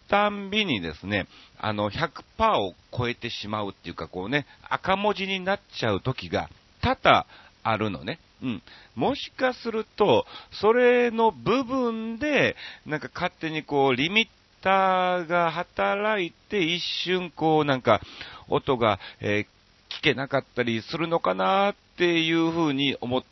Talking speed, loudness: 265 characters per minute, -25 LUFS